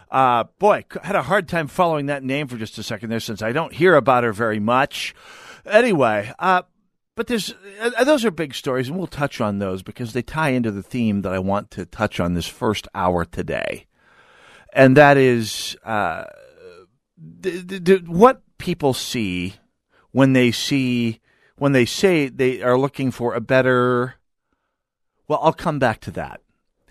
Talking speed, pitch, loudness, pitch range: 180 wpm, 130 Hz, -20 LUFS, 115-175 Hz